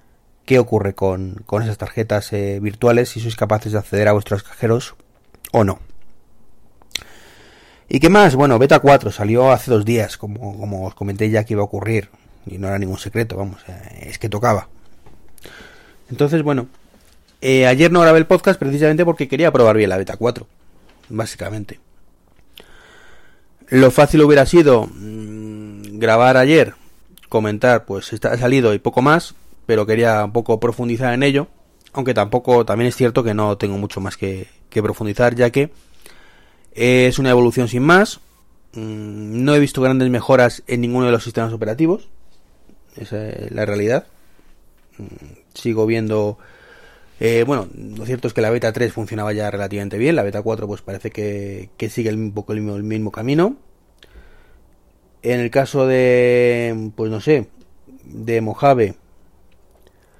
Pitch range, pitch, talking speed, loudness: 105-125 Hz, 110 Hz, 155 wpm, -16 LUFS